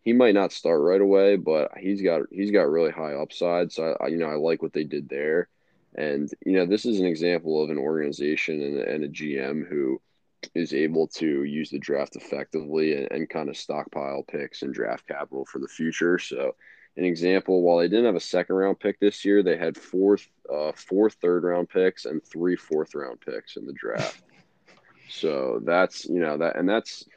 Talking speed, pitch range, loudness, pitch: 210 wpm, 75-95 Hz, -25 LUFS, 85 Hz